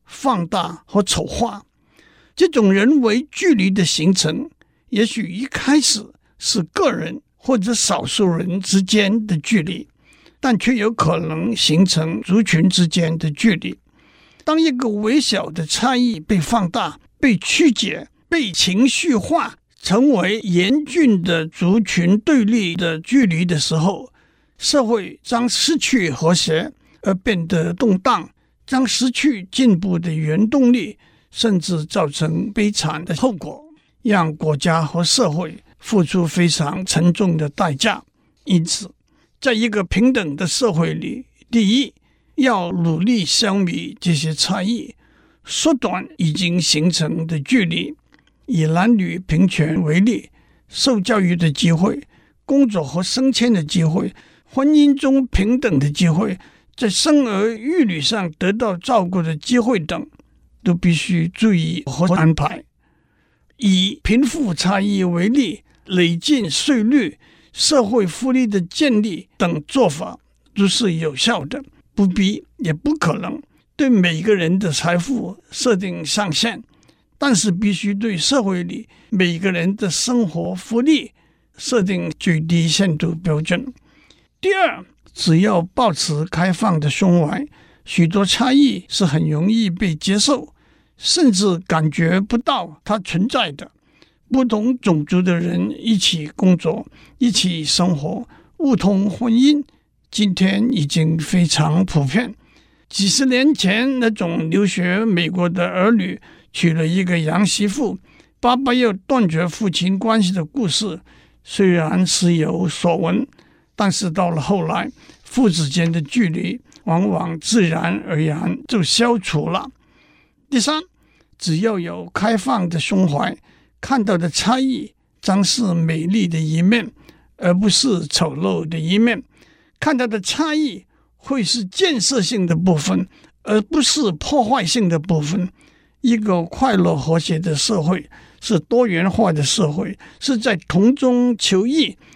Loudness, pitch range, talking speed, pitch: -18 LUFS, 170-240 Hz, 195 characters per minute, 195 Hz